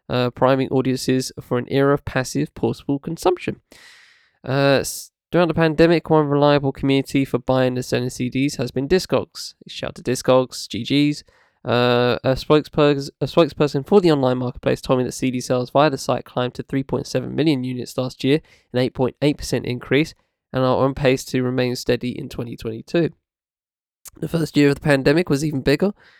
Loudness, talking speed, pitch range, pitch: -20 LUFS, 165 wpm, 125-145 Hz, 135 Hz